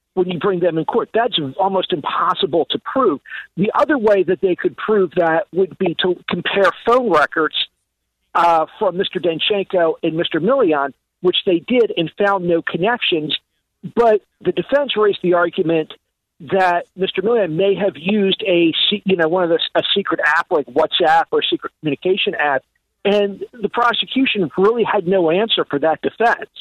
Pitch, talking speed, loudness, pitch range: 190 Hz, 175 wpm, -17 LUFS, 175-210 Hz